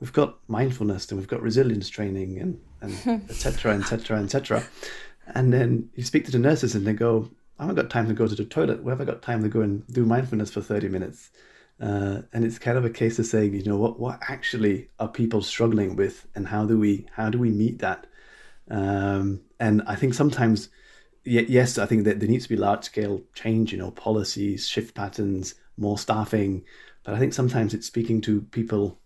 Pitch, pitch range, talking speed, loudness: 110 Hz, 105-120 Hz, 210 wpm, -25 LUFS